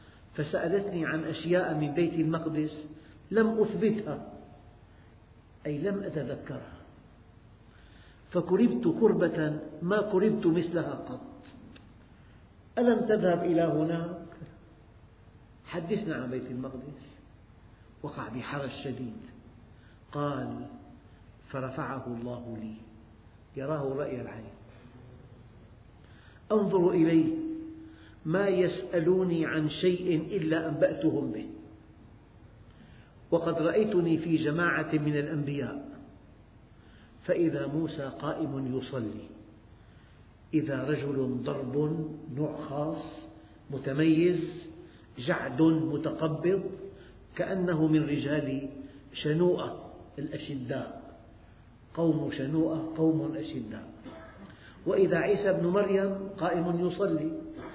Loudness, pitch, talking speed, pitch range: -30 LUFS, 150 Hz, 80 wpm, 115-170 Hz